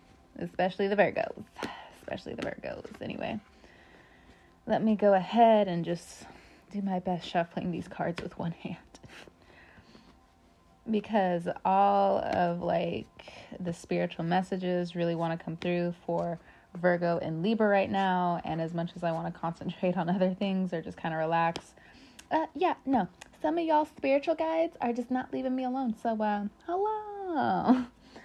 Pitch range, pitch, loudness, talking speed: 170-225 Hz, 185 Hz, -30 LUFS, 155 wpm